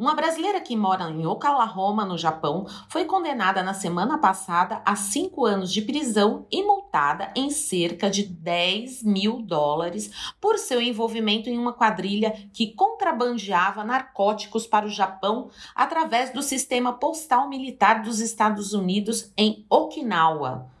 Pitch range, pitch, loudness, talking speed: 195-255 Hz, 220 Hz, -24 LUFS, 140 wpm